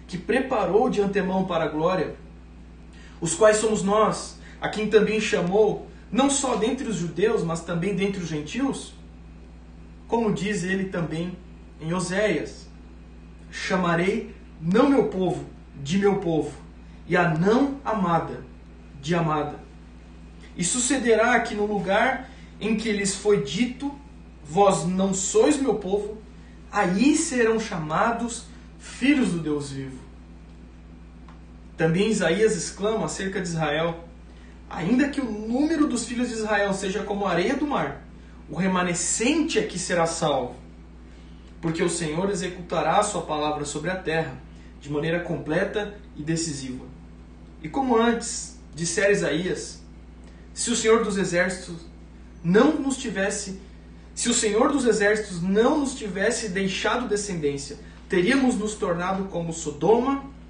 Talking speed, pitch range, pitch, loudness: 135 wpm, 150-215 Hz, 185 Hz, -24 LUFS